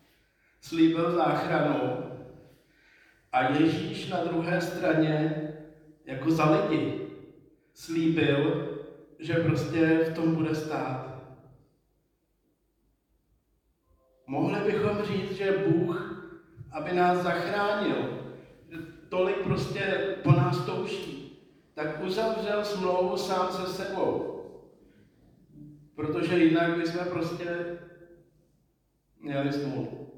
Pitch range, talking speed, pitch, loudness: 155-180 Hz, 85 wpm, 165 Hz, -28 LUFS